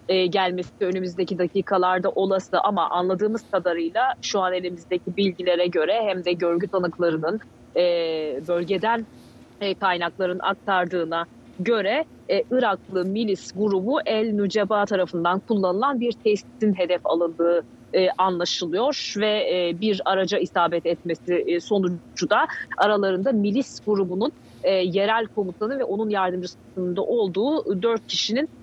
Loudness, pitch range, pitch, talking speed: -23 LUFS, 180-210 Hz, 190 Hz, 120 wpm